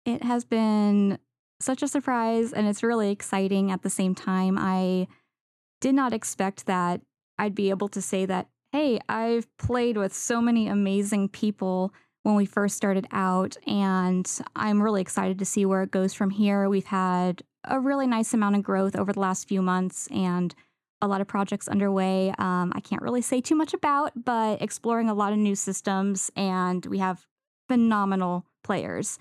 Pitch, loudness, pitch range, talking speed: 200 Hz, -26 LUFS, 190-225 Hz, 180 wpm